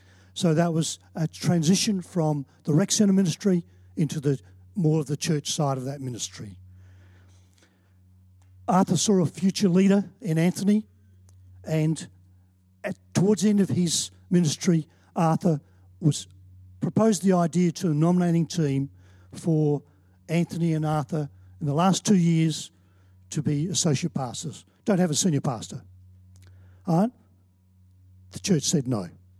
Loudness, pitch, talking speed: -25 LUFS, 150 Hz, 135 wpm